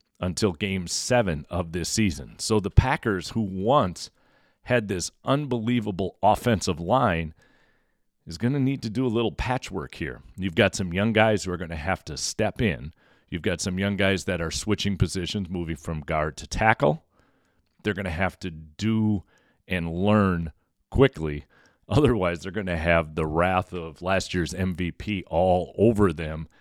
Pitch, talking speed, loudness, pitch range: 95 Hz, 170 wpm, -25 LUFS, 85-110 Hz